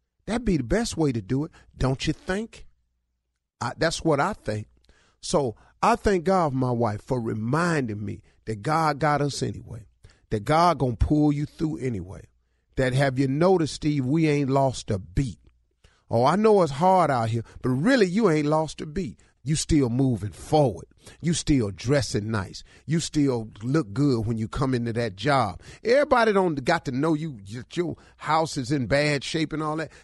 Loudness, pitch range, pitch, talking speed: -24 LUFS, 115-160 Hz, 140 Hz, 190 wpm